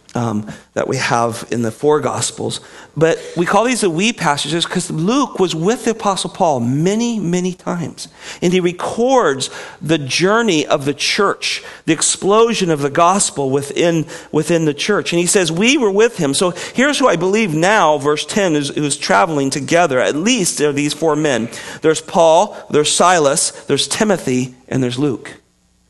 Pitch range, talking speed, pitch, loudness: 145-195 Hz, 180 wpm, 165 Hz, -15 LUFS